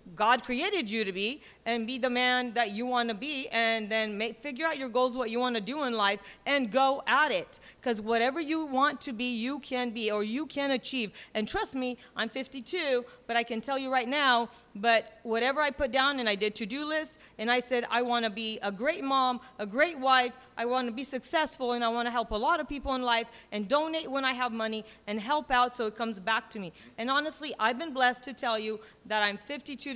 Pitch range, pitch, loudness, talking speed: 225-270 Hz, 245 Hz, -29 LUFS, 245 wpm